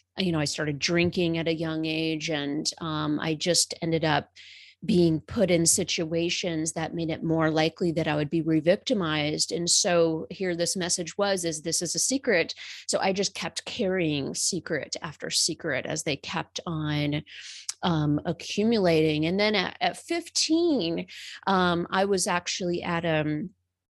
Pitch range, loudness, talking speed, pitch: 155-185 Hz, -26 LUFS, 165 wpm, 165 Hz